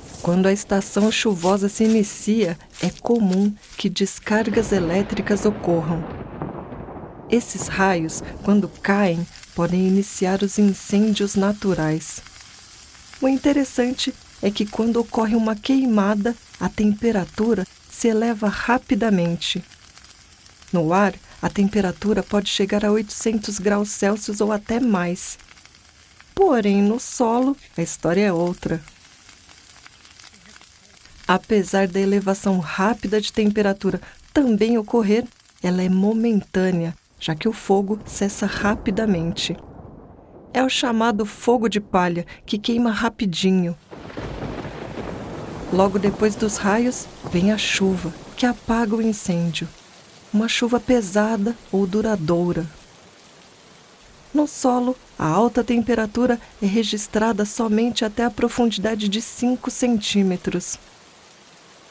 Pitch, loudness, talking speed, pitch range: 210 Hz, -21 LUFS, 105 wpm, 190-230 Hz